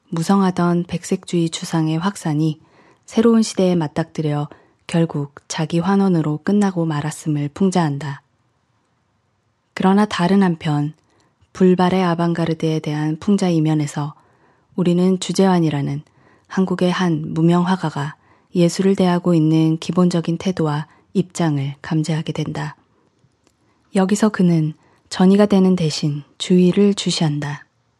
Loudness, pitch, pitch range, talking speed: -18 LUFS, 165 Hz, 150-185 Hz, 275 characters per minute